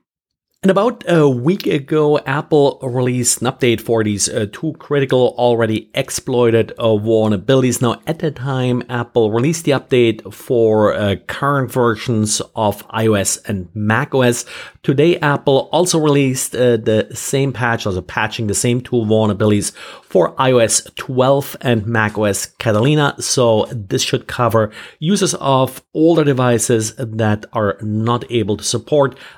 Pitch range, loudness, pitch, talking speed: 110-140 Hz, -16 LUFS, 120 Hz, 140 wpm